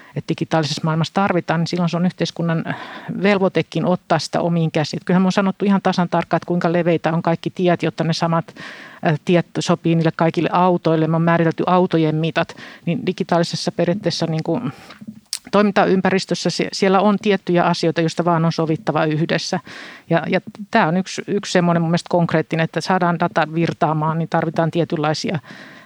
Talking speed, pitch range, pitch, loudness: 165 wpm, 165-180 Hz, 170 Hz, -19 LUFS